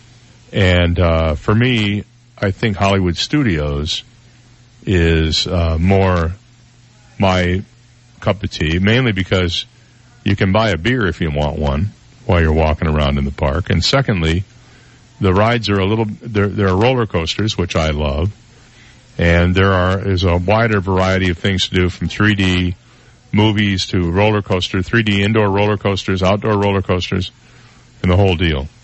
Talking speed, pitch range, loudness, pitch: 155 wpm, 90-115 Hz, -16 LUFS, 100 Hz